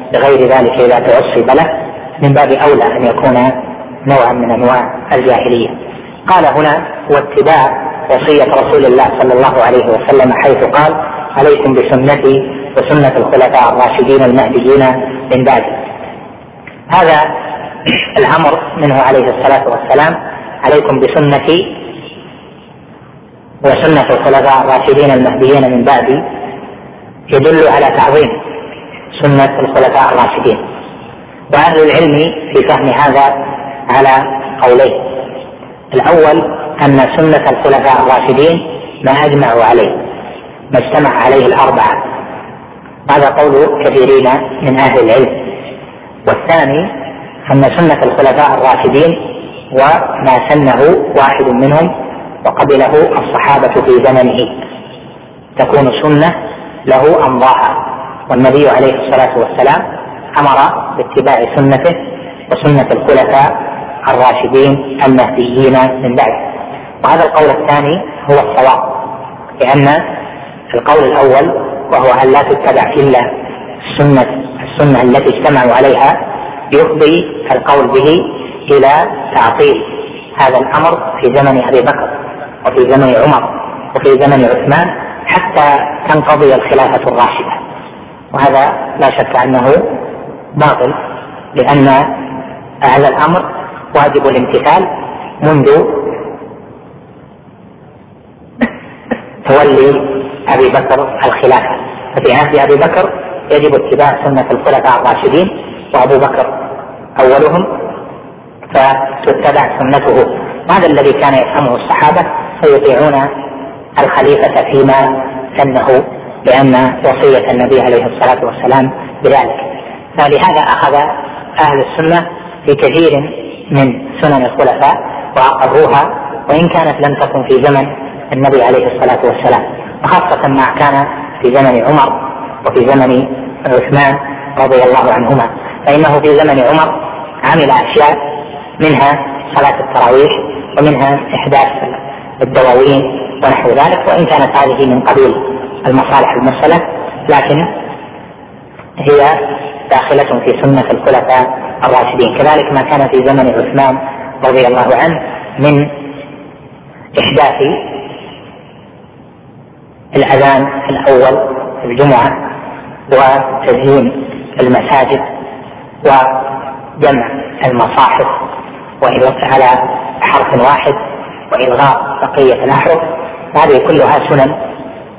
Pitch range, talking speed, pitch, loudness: 130-155 Hz, 95 wpm, 140 Hz, -8 LUFS